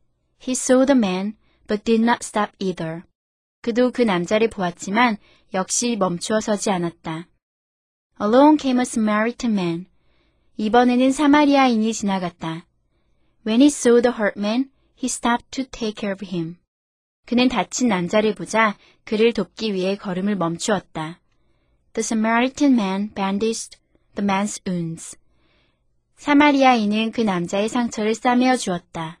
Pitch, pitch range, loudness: 215 Hz, 185-245 Hz, -20 LUFS